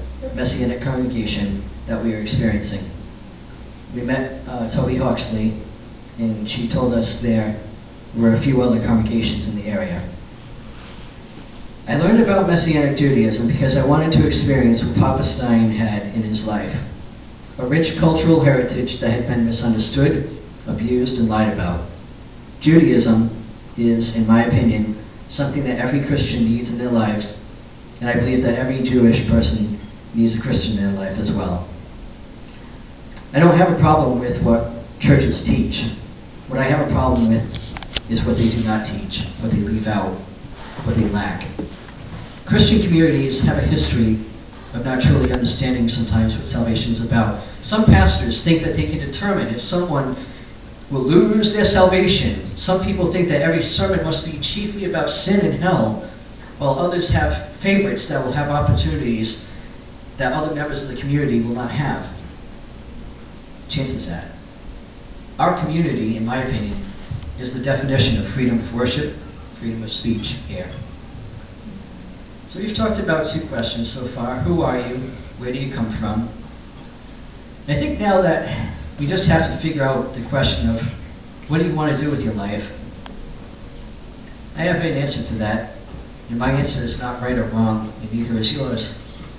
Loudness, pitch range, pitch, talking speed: -19 LUFS, 110-140 Hz, 120 Hz, 160 wpm